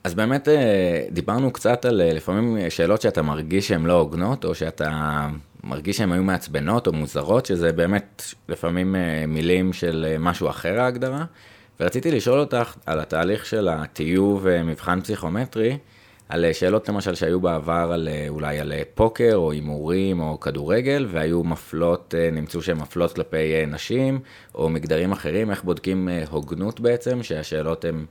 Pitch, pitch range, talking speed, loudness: 90 Hz, 80-105 Hz, 140 wpm, -23 LUFS